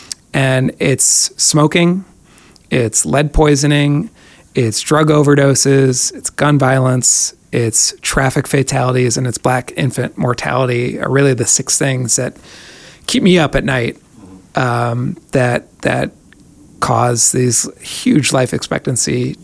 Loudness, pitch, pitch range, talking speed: -13 LUFS, 130 Hz, 125-145 Hz, 120 wpm